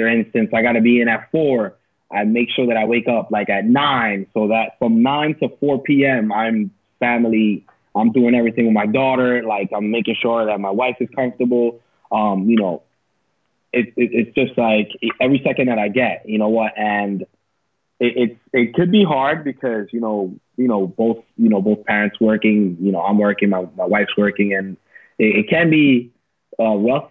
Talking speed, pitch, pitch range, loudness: 200 wpm, 115 Hz, 105-125 Hz, -17 LUFS